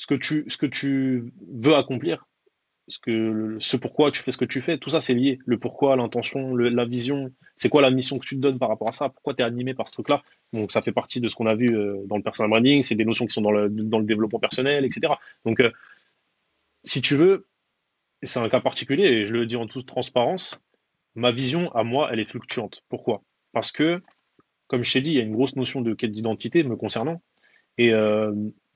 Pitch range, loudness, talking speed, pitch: 115-140 Hz, -23 LUFS, 240 wpm, 125 Hz